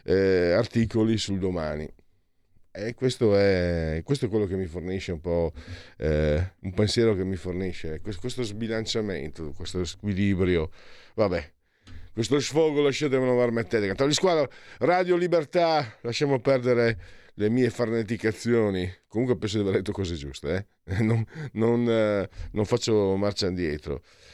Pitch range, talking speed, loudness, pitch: 90-120 Hz, 140 wpm, -26 LUFS, 105 Hz